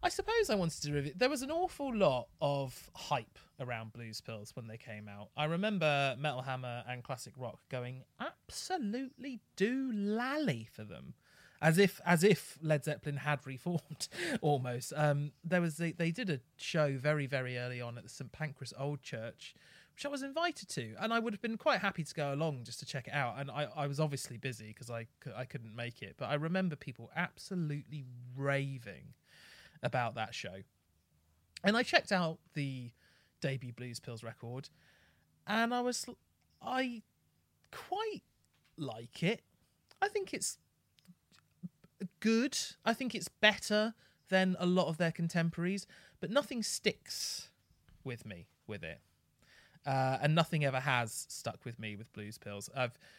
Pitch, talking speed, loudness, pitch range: 145 Hz, 170 wpm, -36 LUFS, 125-190 Hz